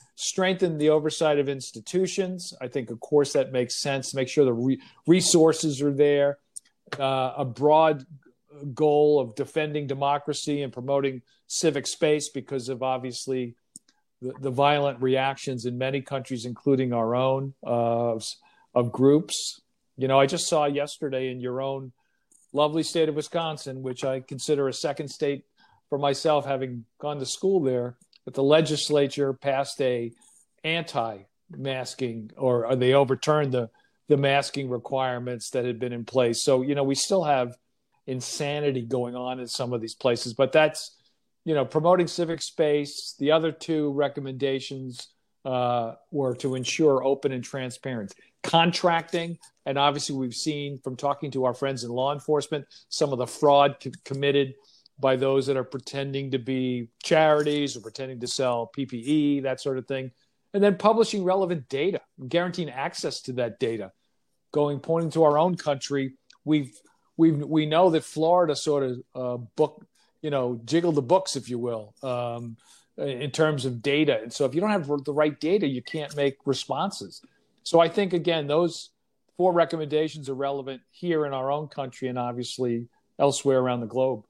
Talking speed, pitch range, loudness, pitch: 165 wpm, 130-150 Hz, -25 LUFS, 140 Hz